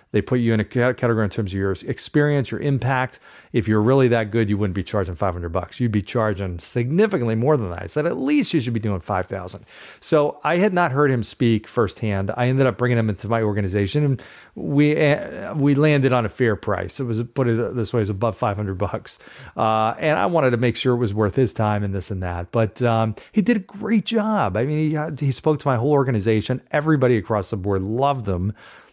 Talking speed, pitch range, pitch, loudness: 235 wpm, 105-140 Hz, 120 Hz, -21 LUFS